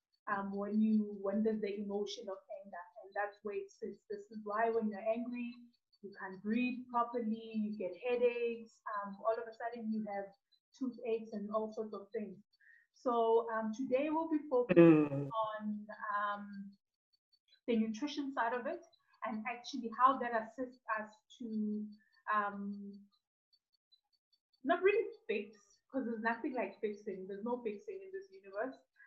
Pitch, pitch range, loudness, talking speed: 220 Hz, 205-245 Hz, -37 LUFS, 150 wpm